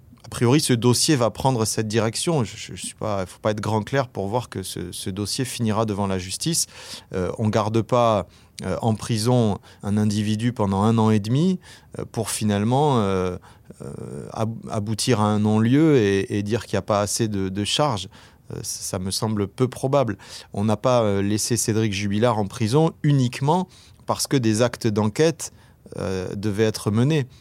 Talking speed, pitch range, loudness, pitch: 185 wpm, 105-125 Hz, -22 LUFS, 110 Hz